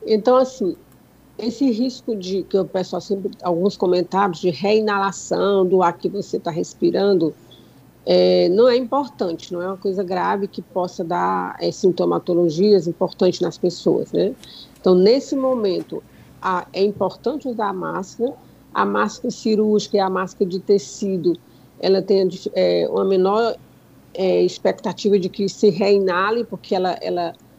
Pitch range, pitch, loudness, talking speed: 180-210 Hz, 195 Hz, -20 LUFS, 150 wpm